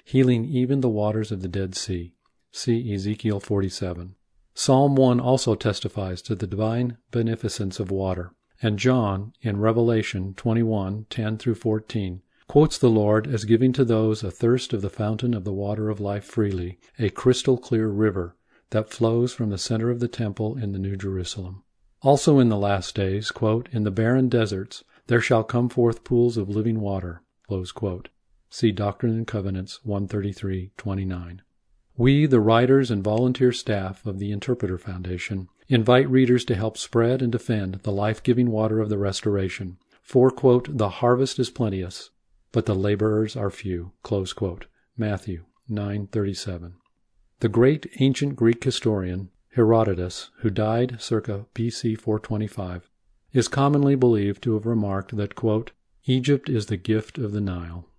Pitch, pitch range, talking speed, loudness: 110 Hz, 100-120 Hz, 155 wpm, -24 LUFS